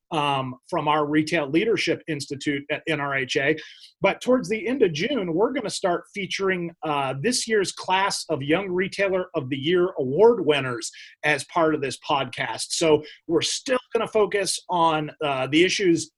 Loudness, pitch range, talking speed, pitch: -23 LUFS, 150-195 Hz, 170 wpm, 170 Hz